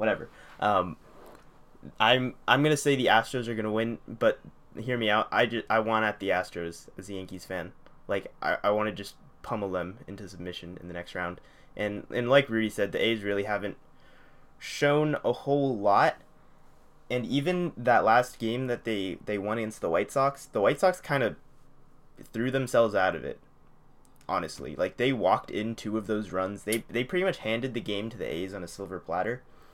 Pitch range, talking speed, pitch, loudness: 100-125 Hz, 200 wpm, 110 Hz, -28 LUFS